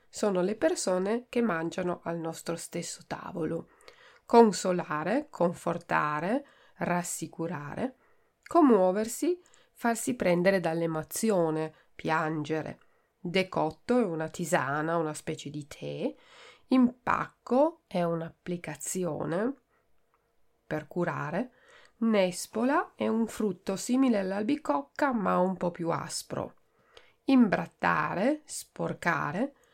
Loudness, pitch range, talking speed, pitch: -29 LUFS, 165-240 Hz, 85 wpm, 185 Hz